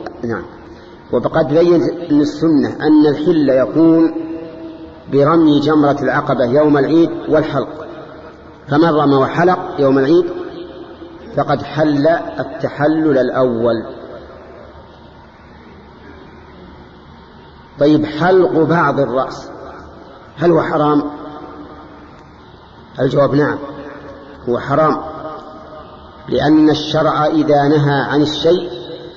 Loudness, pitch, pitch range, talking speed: -14 LUFS, 150 Hz, 140-160 Hz, 80 wpm